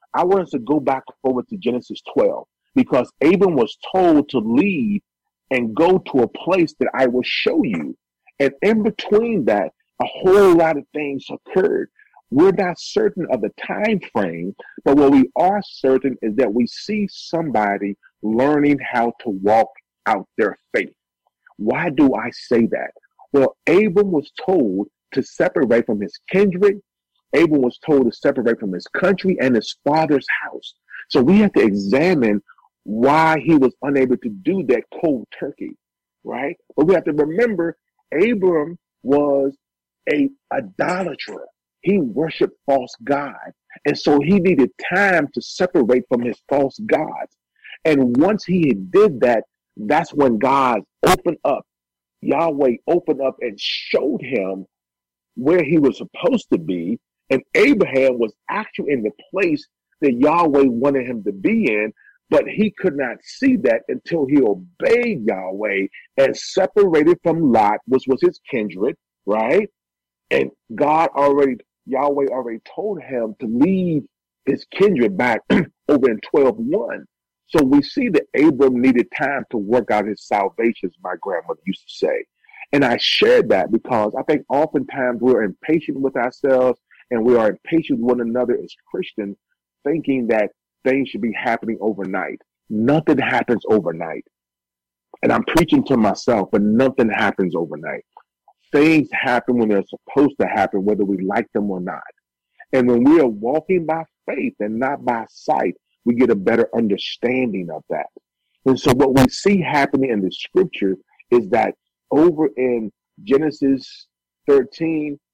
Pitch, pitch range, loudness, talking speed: 140 Hz, 120-195 Hz, -18 LUFS, 155 wpm